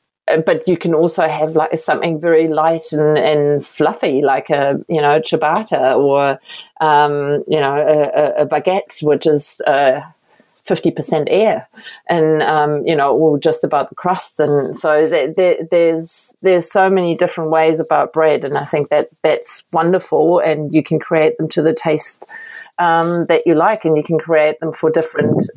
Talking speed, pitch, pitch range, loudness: 180 wpm, 160 Hz, 150-170 Hz, -15 LUFS